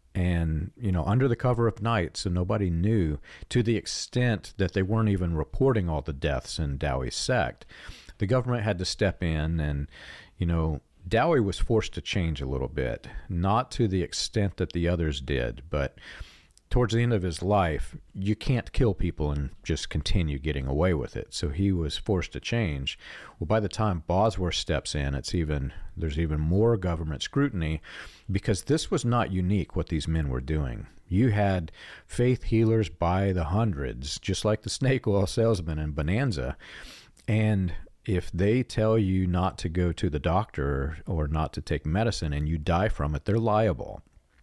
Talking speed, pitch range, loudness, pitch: 185 wpm, 80-110 Hz, -28 LUFS, 90 Hz